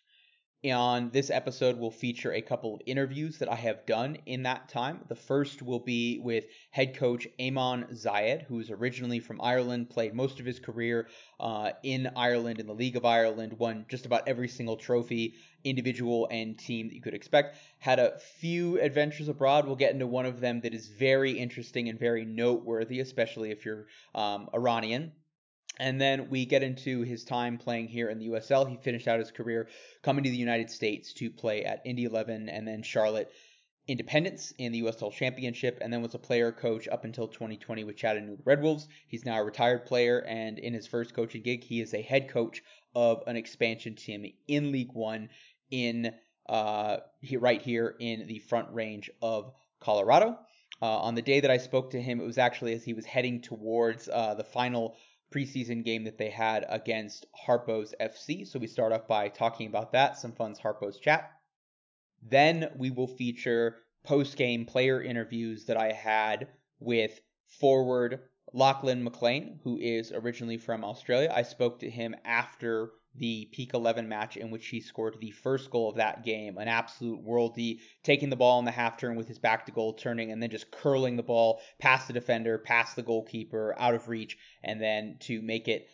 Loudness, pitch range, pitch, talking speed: -31 LUFS, 115-130 Hz, 120 Hz, 190 wpm